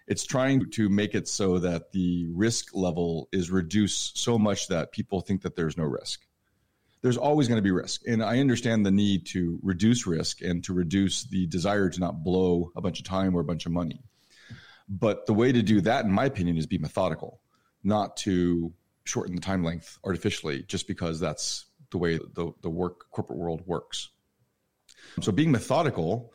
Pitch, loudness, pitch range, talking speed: 95 Hz, -27 LUFS, 85-105 Hz, 195 wpm